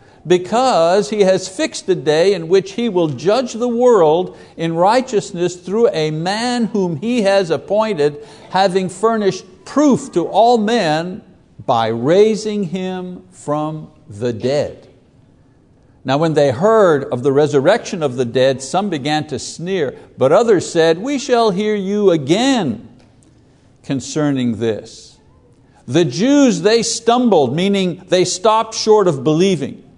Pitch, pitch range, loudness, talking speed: 185 Hz, 150-215 Hz, -16 LUFS, 135 wpm